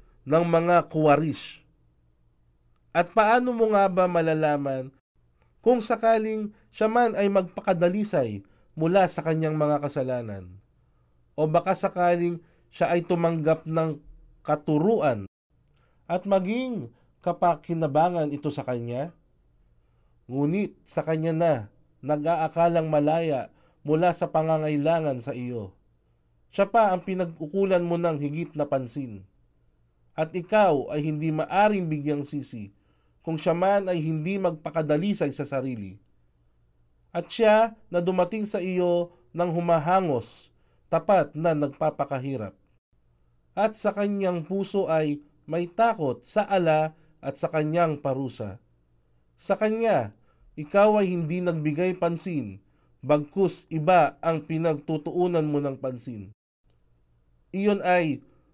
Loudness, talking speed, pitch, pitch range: -25 LUFS, 110 wpm, 155 Hz, 125-180 Hz